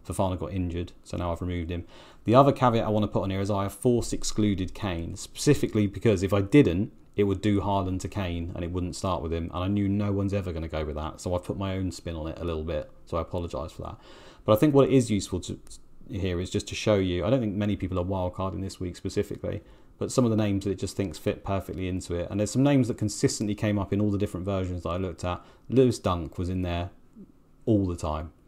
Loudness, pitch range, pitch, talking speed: -27 LUFS, 90-105 Hz, 95 Hz, 275 wpm